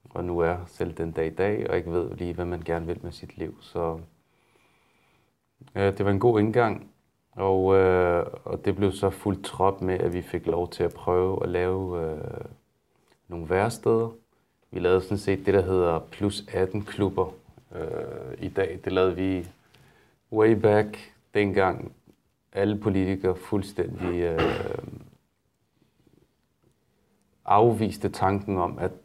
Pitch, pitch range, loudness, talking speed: 95 Hz, 90-100 Hz, -26 LUFS, 150 wpm